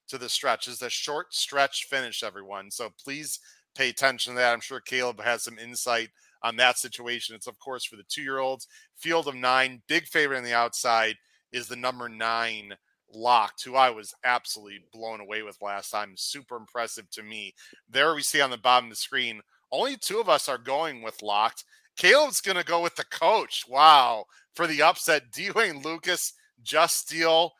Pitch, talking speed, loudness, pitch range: 125 Hz, 195 wpm, -25 LUFS, 115-145 Hz